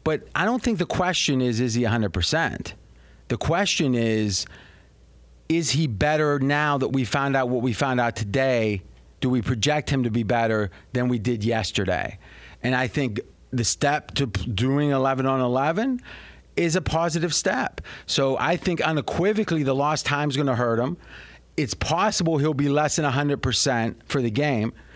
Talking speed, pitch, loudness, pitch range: 175 wpm, 135 Hz, -23 LUFS, 115-150 Hz